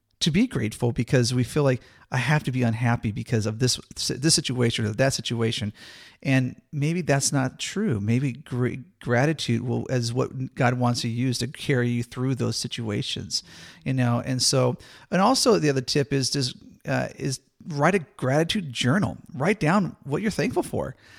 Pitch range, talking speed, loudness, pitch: 120-145 Hz, 180 wpm, -25 LUFS, 130 Hz